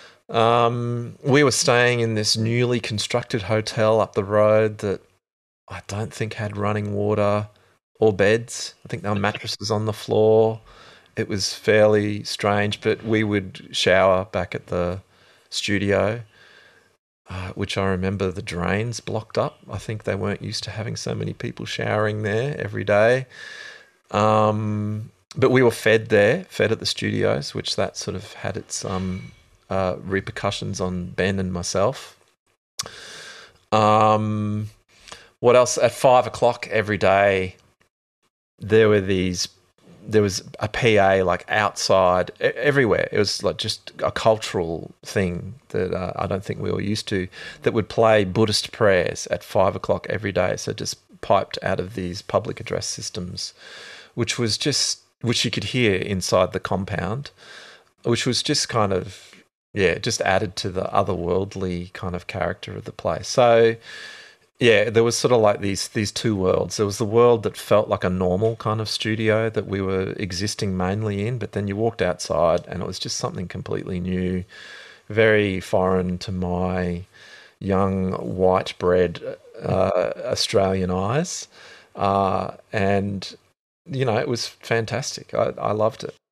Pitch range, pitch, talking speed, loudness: 95-115 Hz, 105 Hz, 160 wpm, -22 LUFS